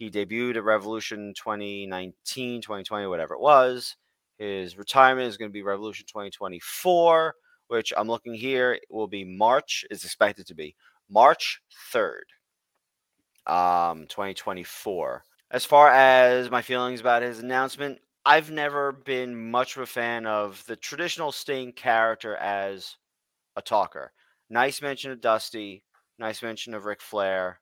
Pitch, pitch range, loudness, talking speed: 115 Hz, 105-130 Hz, -24 LUFS, 140 wpm